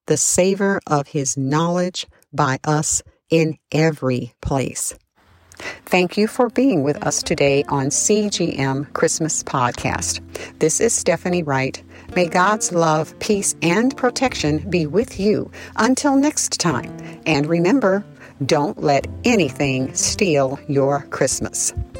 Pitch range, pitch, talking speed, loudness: 140-195 Hz, 160 Hz, 125 wpm, -19 LUFS